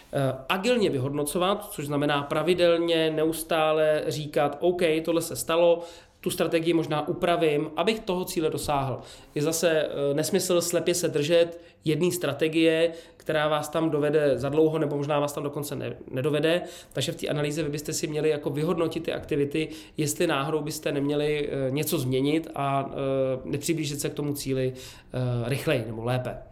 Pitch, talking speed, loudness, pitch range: 155 Hz, 150 wpm, -26 LUFS, 145-165 Hz